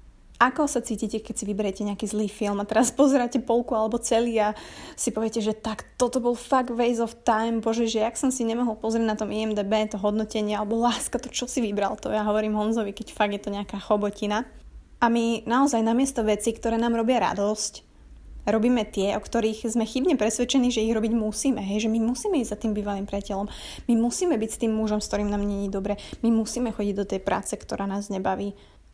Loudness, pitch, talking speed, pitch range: -25 LUFS, 220 Hz, 215 wpm, 210-235 Hz